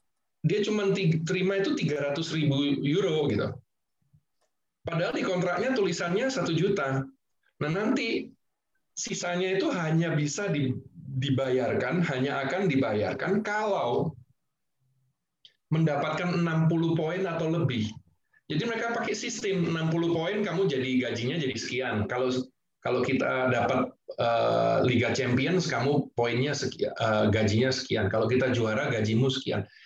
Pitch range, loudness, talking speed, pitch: 130-175 Hz, -28 LUFS, 115 wpm, 145 Hz